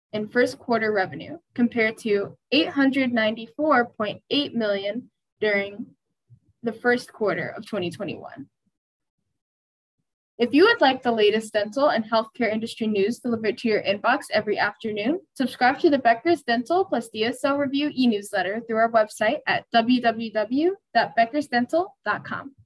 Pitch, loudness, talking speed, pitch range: 230 Hz, -23 LUFS, 140 wpm, 215-275 Hz